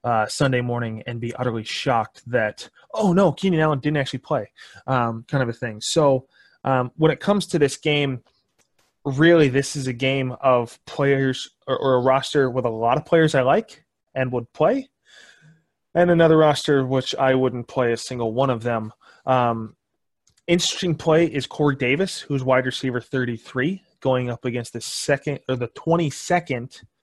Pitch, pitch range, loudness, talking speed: 130 Hz, 125-155 Hz, -21 LUFS, 175 wpm